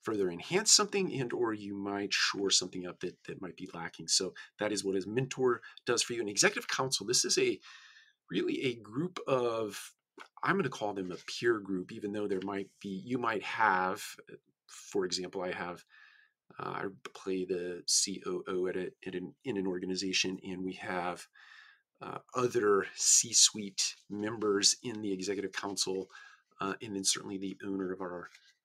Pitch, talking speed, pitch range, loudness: 100 Hz, 180 wpm, 95-135 Hz, -32 LUFS